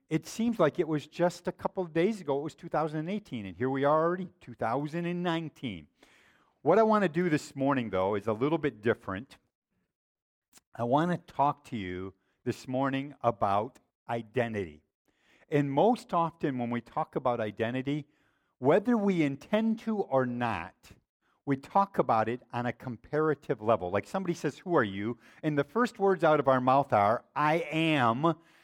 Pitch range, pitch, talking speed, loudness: 120-170 Hz, 145 Hz, 170 wpm, -30 LUFS